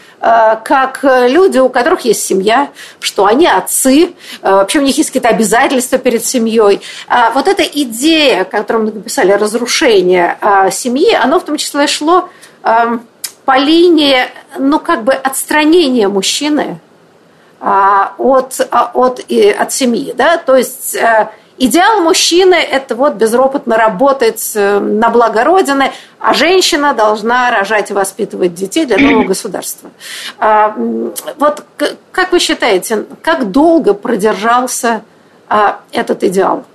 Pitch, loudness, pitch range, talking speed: 255 Hz, -10 LUFS, 220-305 Hz, 120 wpm